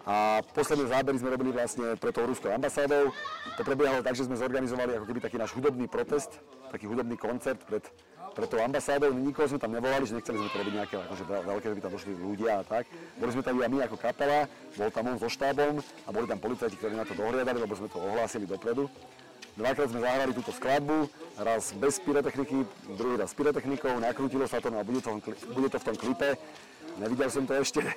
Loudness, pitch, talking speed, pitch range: -31 LUFS, 125 Hz, 215 wpm, 110-140 Hz